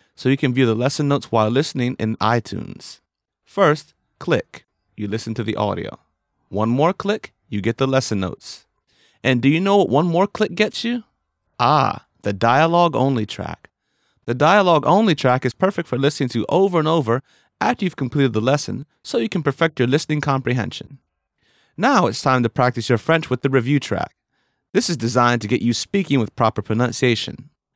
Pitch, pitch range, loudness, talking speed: 130 Hz, 115-160 Hz, -19 LUFS, 185 wpm